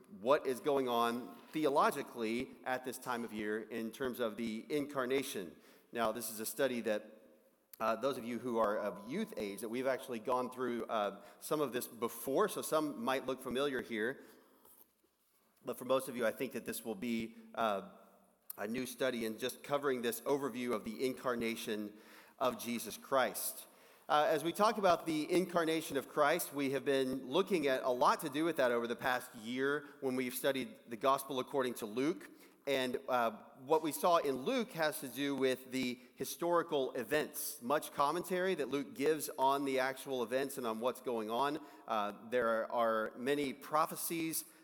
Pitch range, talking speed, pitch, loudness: 120-145 Hz, 185 wpm, 130 Hz, -37 LUFS